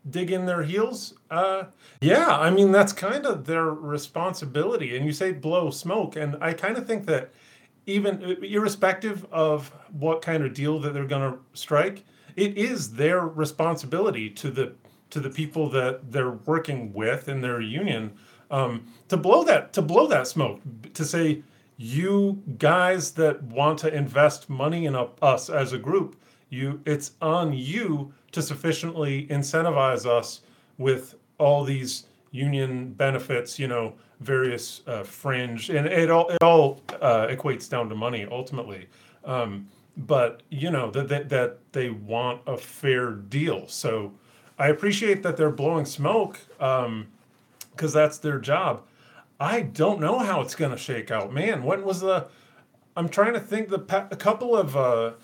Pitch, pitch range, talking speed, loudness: 145 Hz, 130-165 Hz, 165 wpm, -25 LUFS